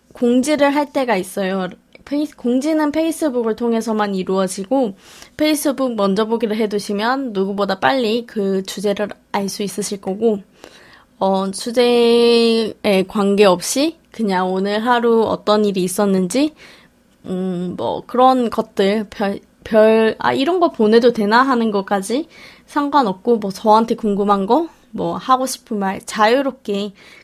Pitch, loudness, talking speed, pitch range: 220 Hz, -17 LUFS, 275 characters per minute, 200-250 Hz